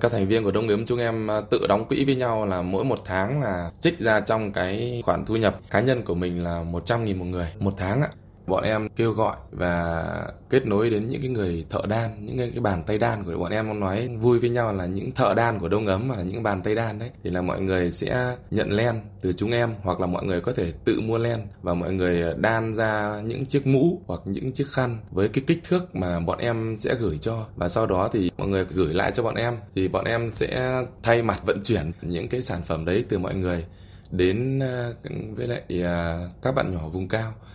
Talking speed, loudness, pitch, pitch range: 240 wpm, -25 LUFS, 105 Hz, 90-120 Hz